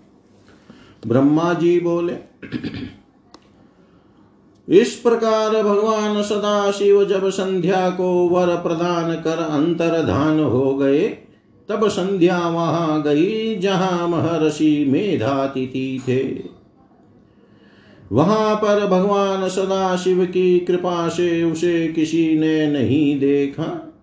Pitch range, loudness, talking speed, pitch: 155-195 Hz, -18 LUFS, 90 wpm, 175 Hz